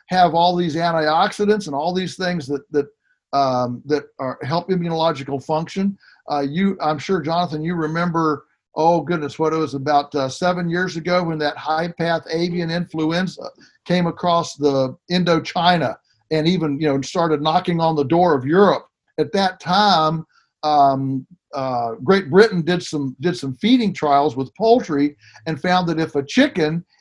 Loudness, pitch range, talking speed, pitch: -19 LUFS, 145-180 Hz, 165 wpm, 165 Hz